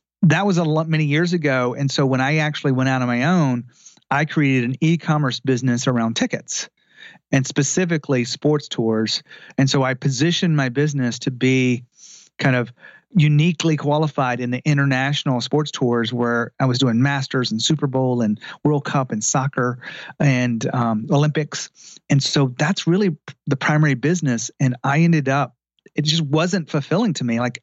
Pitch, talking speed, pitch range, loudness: 140 Hz, 170 wpm, 125-155 Hz, -20 LUFS